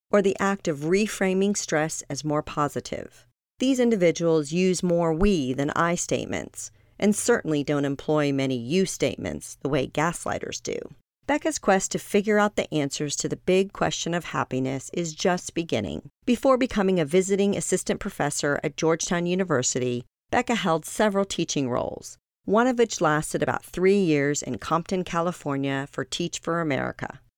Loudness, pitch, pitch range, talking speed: -25 LUFS, 170 Hz, 145-195 Hz, 160 wpm